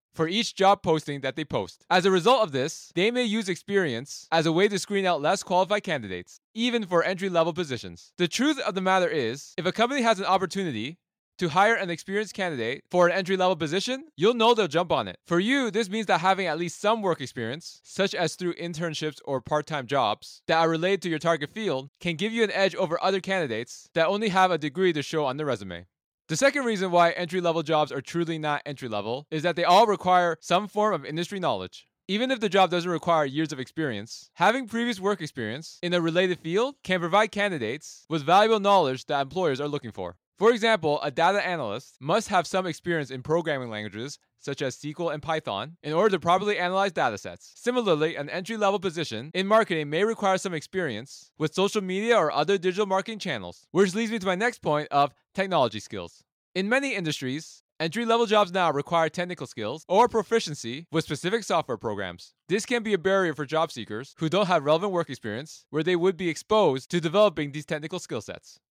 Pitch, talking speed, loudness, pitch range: 175 Hz, 210 wpm, -26 LUFS, 150-195 Hz